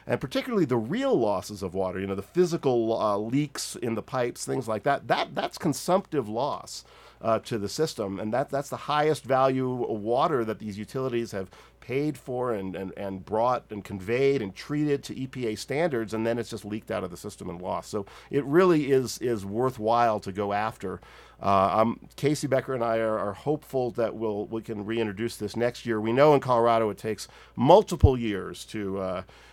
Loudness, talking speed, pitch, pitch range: -27 LUFS, 200 wpm, 115 Hz, 105-130 Hz